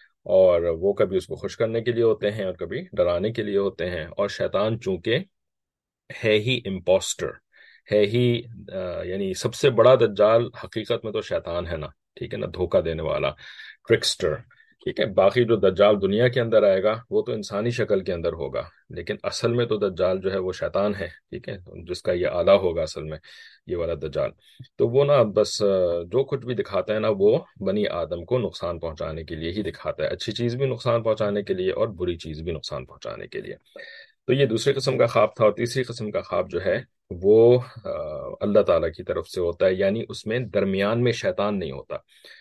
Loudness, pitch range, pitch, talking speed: -23 LUFS, 100-135 Hz, 115 Hz, 210 wpm